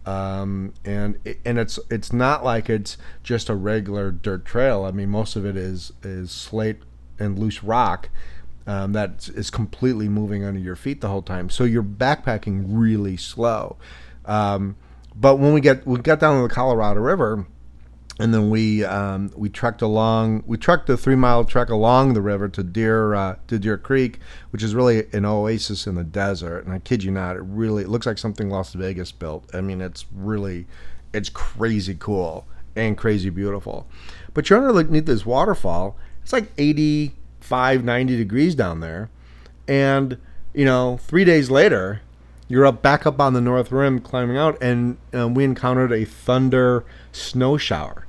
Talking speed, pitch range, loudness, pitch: 180 wpm, 95-125 Hz, -21 LUFS, 105 Hz